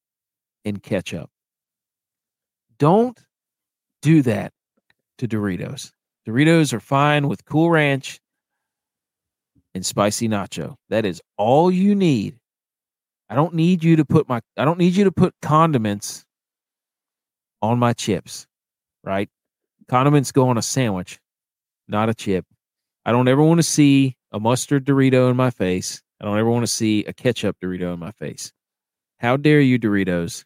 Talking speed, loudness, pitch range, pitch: 150 wpm, -19 LUFS, 105-150 Hz, 125 Hz